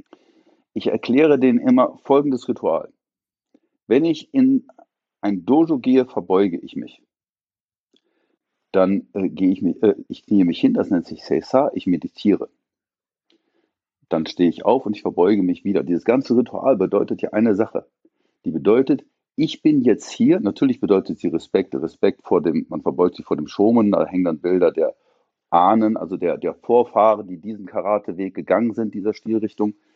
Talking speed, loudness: 165 wpm, -19 LUFS